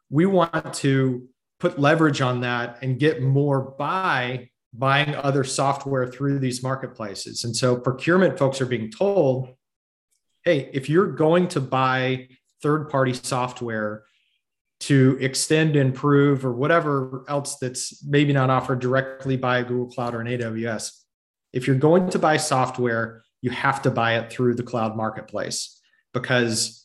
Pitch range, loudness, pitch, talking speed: 125-140 Hz, -22 LUFS, 130 Hz, 145 wpm